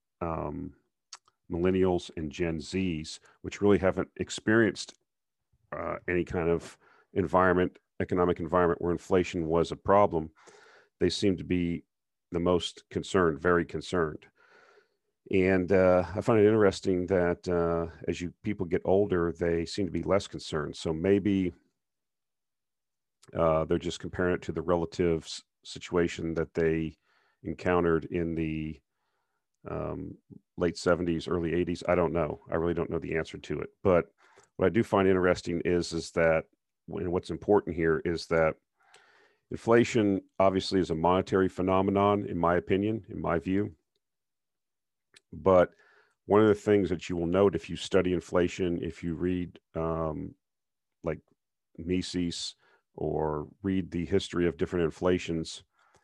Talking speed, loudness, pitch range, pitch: 145 wpm, -29 LUFS, 85-95 Hz, 90 Hz